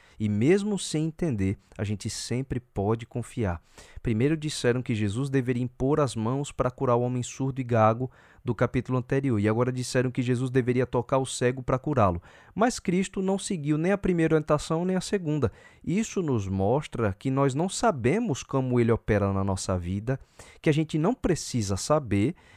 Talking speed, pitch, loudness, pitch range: 180 wpm, 130 Hz, -27 LUFS, 110-150 Hz